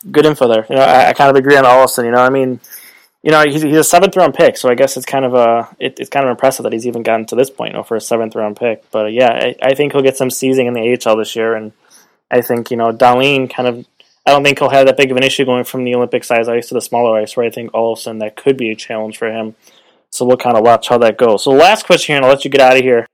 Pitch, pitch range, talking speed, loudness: 125 Hz, 115-135 Hz, 320 wpm, -12 LUFS